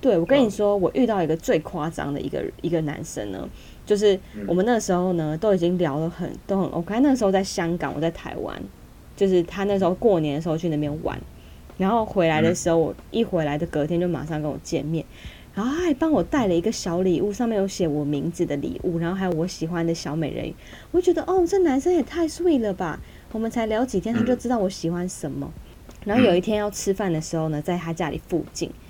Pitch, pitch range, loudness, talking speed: 180 Hz, 160-220 Hz, -23 LUFS, 350 characters per minute